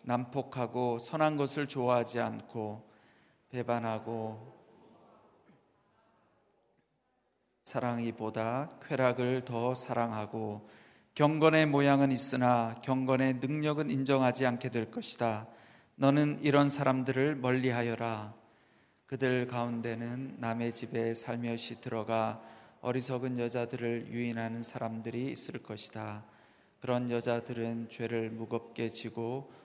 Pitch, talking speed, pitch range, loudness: 120 Hz, 240 characters per minute, 115-130 Hz, -33 LUFS